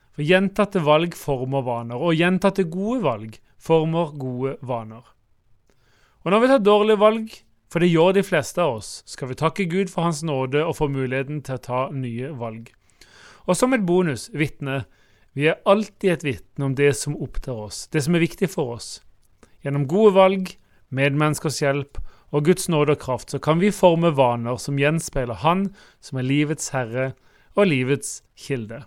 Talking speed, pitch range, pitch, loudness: 175 wpm, 130-175 Hz, 145 Hz, -21 LUFS